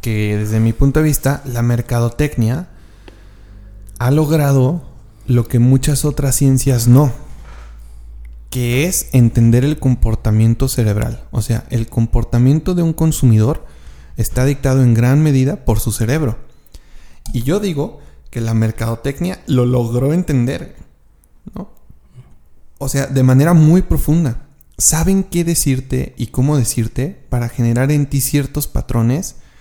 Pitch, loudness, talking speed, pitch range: 125 Hz, -15 LUFS, 130 wpm, 115-140 Hz